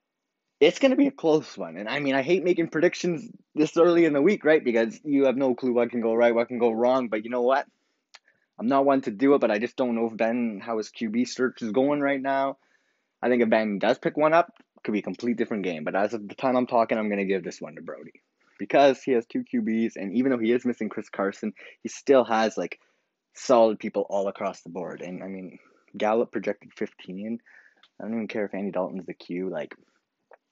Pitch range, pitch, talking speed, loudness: 110-140 Hz, 120 Hz, 245 wpm, -25 LUFS